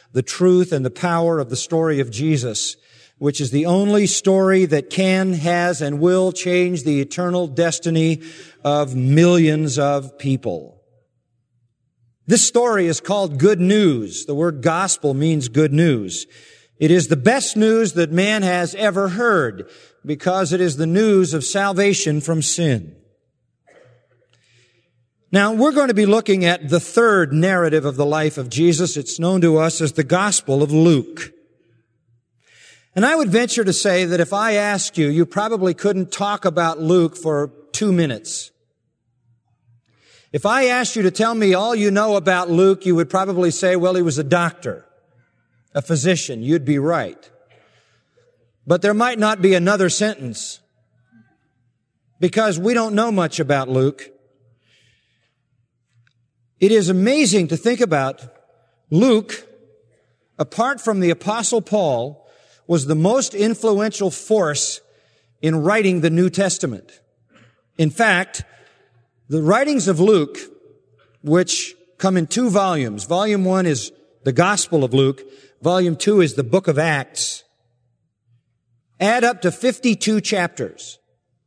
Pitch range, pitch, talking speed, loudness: 135-195 Hz, 170 Hz, 145 wpm, -18 LUFS